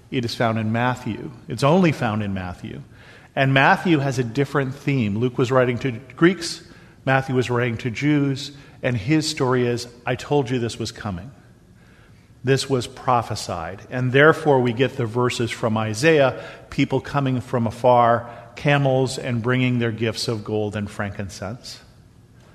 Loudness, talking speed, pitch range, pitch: -21 LUFS, 160 wpm, 115-135 Hz, 125 Hz